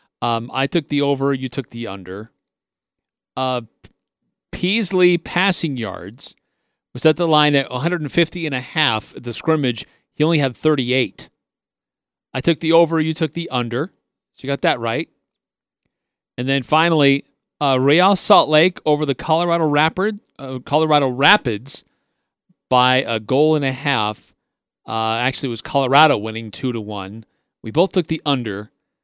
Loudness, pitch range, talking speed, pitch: -18 LUFS, 125-160 Hz, 155 wpm, 140 Hz